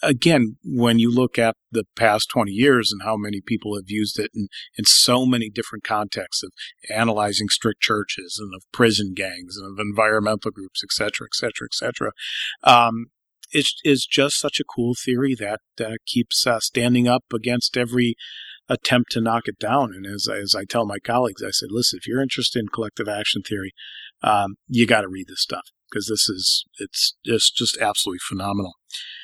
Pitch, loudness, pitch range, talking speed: 115 Hz, -21 LUFS, 105-125 Hz, 185 wpm